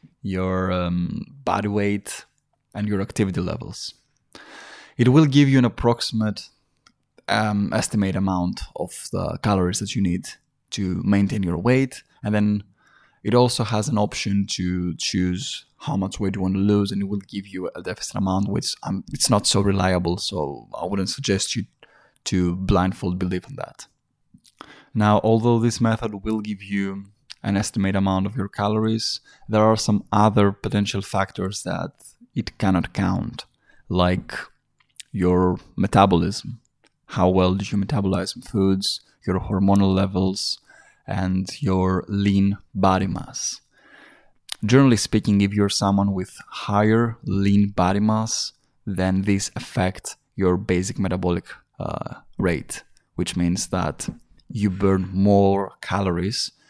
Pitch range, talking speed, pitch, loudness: 95-105 Hz, 140 wpm, 100 Hz, -22 LUFS